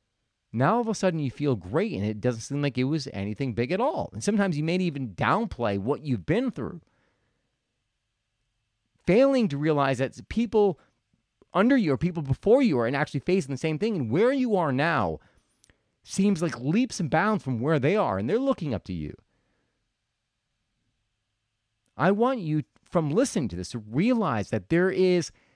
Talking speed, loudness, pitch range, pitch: 185 wpm, -26 LUFS, 115-185 Hz, 140 Hz